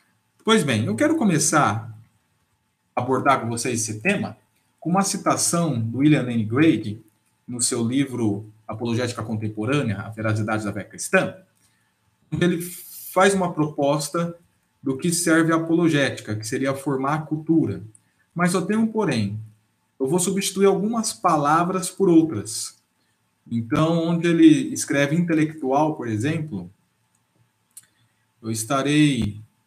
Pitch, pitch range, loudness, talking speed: 135 Hz, 110-170 Hz, -22 LUFS, 125 wpm